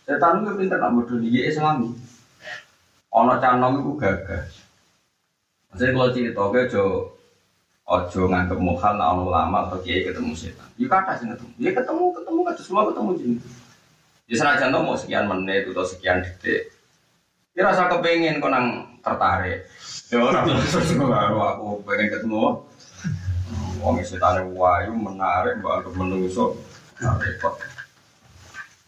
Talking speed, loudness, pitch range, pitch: 135 wpm, -22 LUFS, 95-155 Hz, 120 Hz